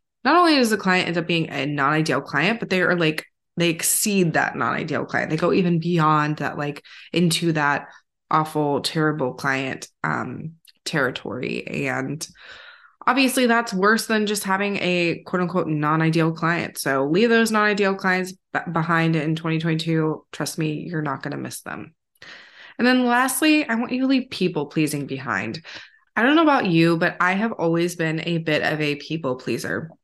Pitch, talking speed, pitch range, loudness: 165 Hz, 180 wpm, 155-200 Hz, -21 LUFS